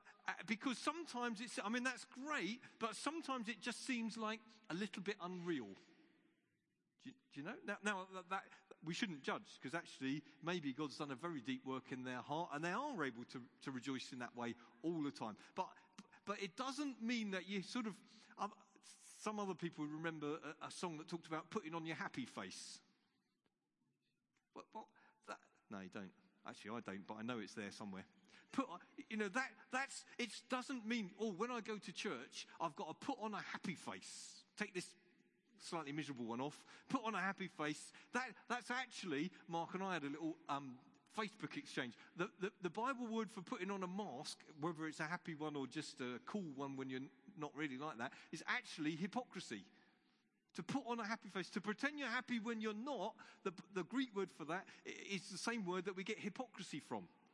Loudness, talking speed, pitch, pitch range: -46 LUFS, 205 wpm, 195 Hz, 155-235 Hz